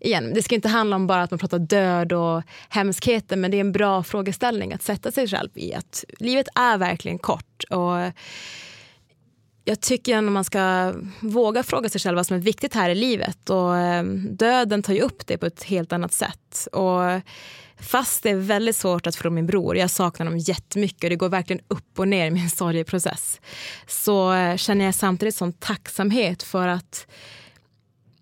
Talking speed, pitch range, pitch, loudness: 190 wpm, 175-205 Hz, 185 Hz, -23 LUFS